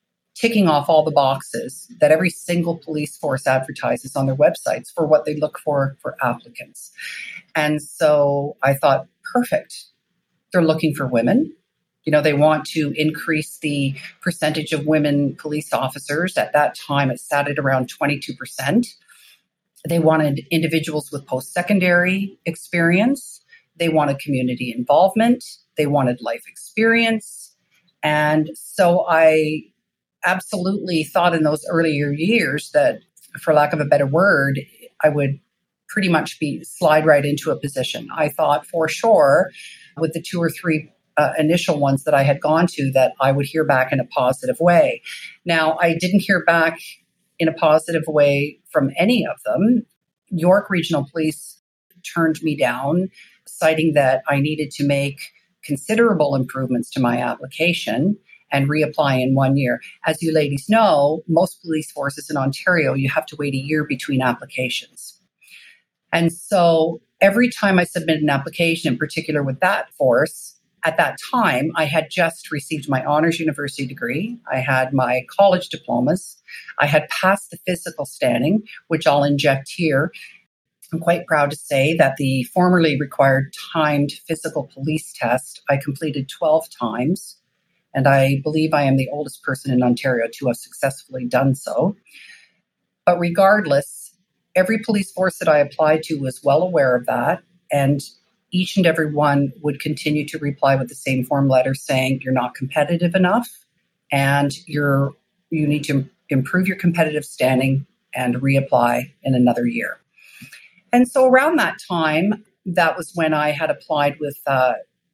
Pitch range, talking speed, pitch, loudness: 140-175 Hz, 155 wpm, 155 Hz, -19 LUFS